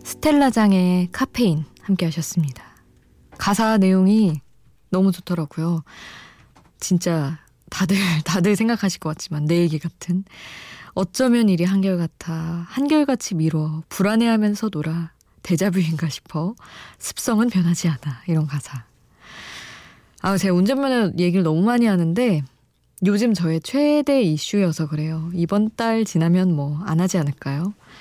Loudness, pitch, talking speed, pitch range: -20 LUFS, 180 Hz, 285 characters per minute, 160-205 Hz